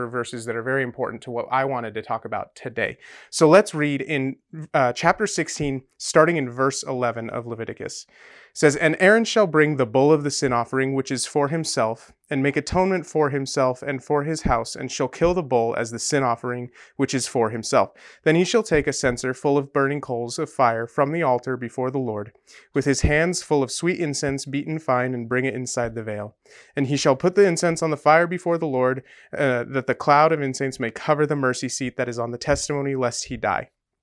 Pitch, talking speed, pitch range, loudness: 135 Hz, 225 wpm, 125-155 Hz, -22 LUFS